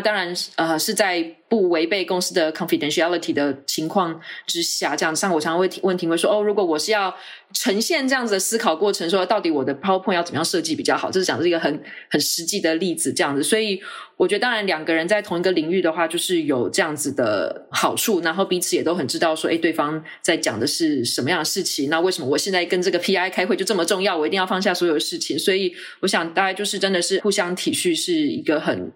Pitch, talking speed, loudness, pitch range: 185 Hz, 410 characters per minute, -21 LUFS, 165-210 Hz